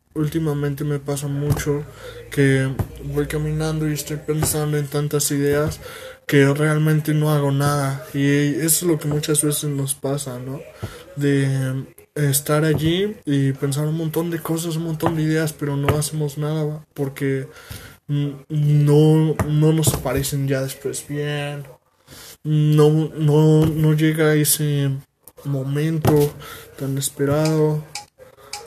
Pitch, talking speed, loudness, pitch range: 150 Hz, 130 wpm, -20 LUFS, 140-155 Hz